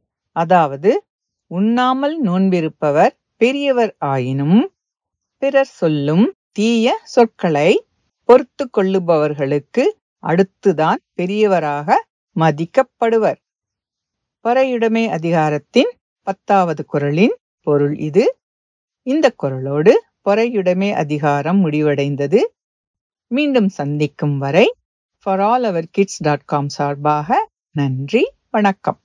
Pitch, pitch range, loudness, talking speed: 195 Hz, 150-245 Hz, -17 LUFS, 75 wpm